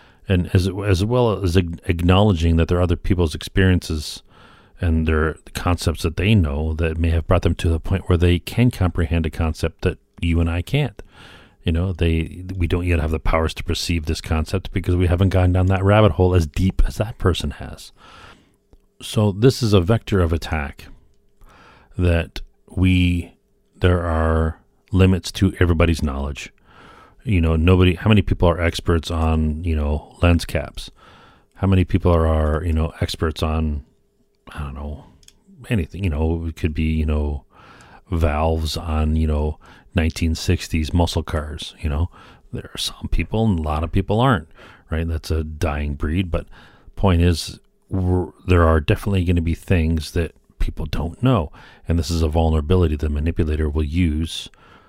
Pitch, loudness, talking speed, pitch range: 85 Hz, -20 LUFS, 175 wpm, 80-95 Hz